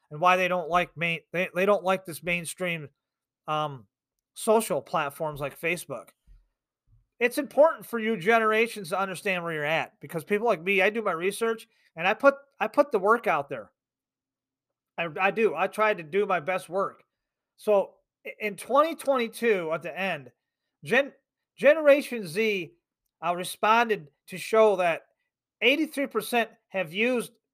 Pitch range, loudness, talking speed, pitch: 170-225 Hz, -26 LUFS, 155 wpm, 195 Hz